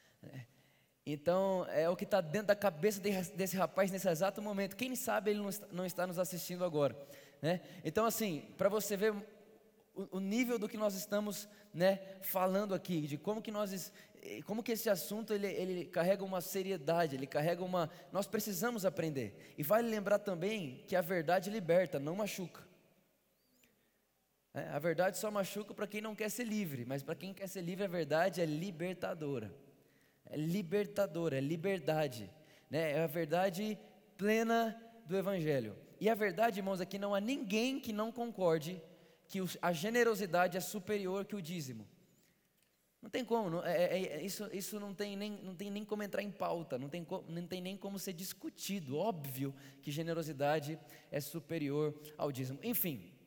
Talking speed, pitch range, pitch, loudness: 175 wpm, 165-210 Hz, 190 Hz, -37 LUFS